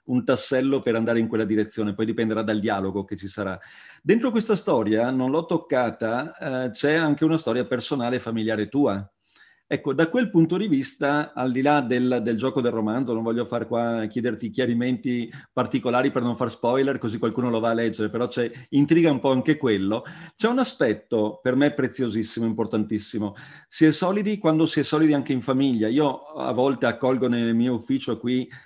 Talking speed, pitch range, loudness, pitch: 195 wpm, 115-140 Hz, -24 LUFS, 125 Hz